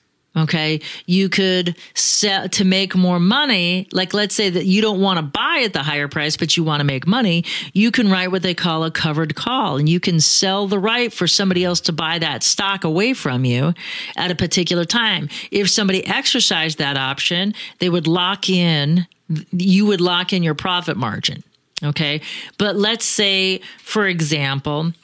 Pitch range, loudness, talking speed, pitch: 160-195 Hz, -17 LUFS, 185 wpm, 180 Hz